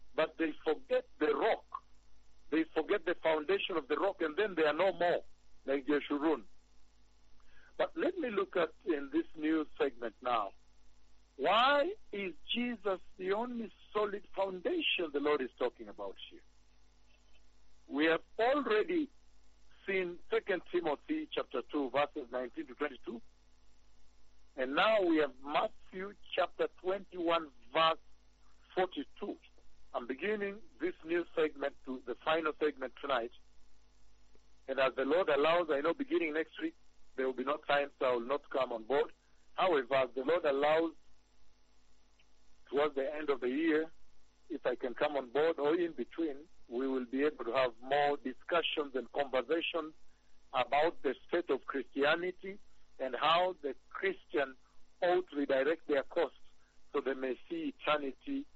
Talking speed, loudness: 150 wpm, -35 LUFS